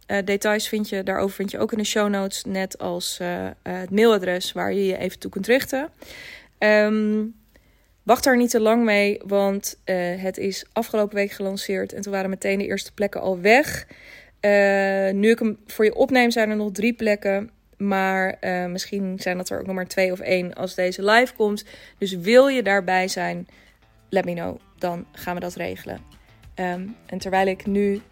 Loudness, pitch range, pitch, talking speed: -22 LUFS, 185-215 Hz, 195 Hz, 200 wpm